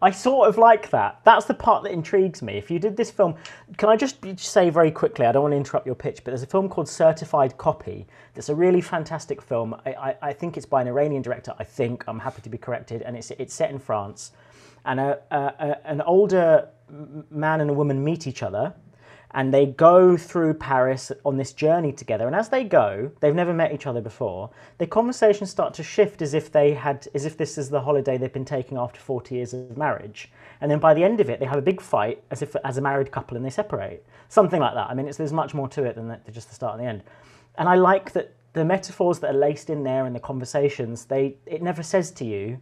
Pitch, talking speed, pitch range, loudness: 145 Hz, 250 wpm, 130-175 Hz, -22 LUFS